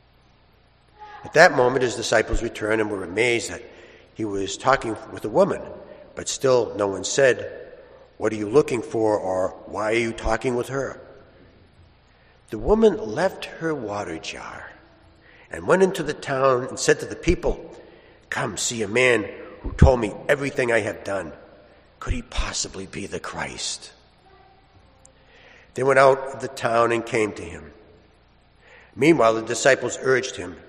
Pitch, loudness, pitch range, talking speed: 125 Hz, -22 LUFS, 110-160 Hz, 160 wpm